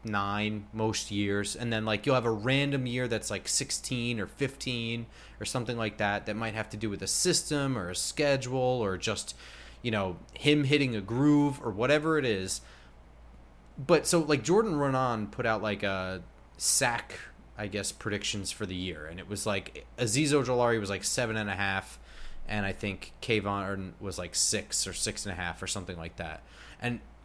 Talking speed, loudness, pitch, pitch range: 195 wpm, -30 LUFS, 105 Hz, 95-125 Hz